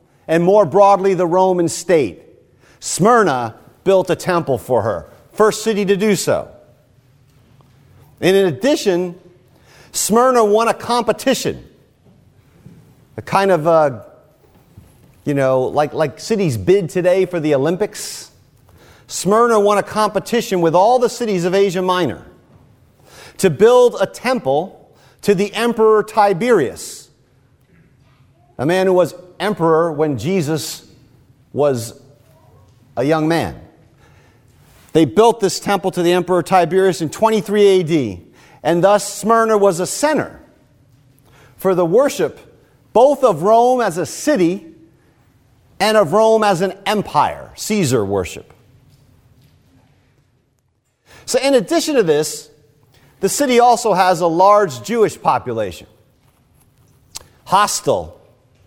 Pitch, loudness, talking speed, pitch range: 180 Hz, -15 LUFS, 120 wpm, 140-205 Hz